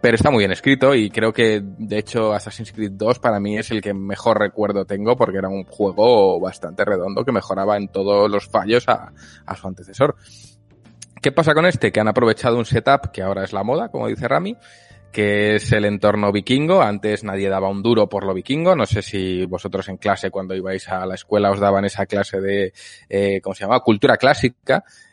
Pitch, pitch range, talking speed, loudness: 105 Hz, 95-115 Hz, 215 wpm, -19 LUFS